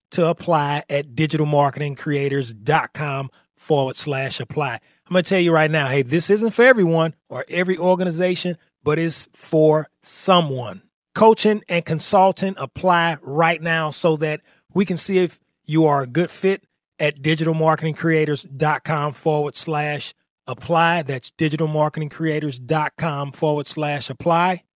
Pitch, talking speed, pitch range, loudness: 155 Hz, 125 wpm, 145-170 Hz, -20 LUFS